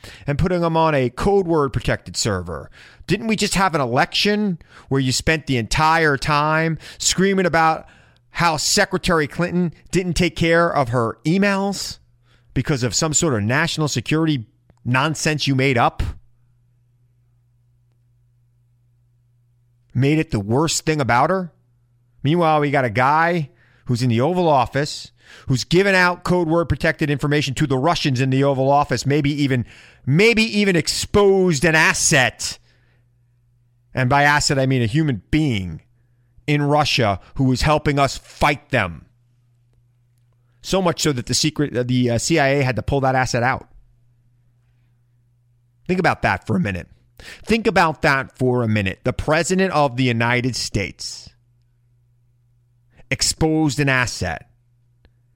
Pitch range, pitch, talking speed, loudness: 120-160 Hz, 130 Hz, 145 wpm, -19 LUFS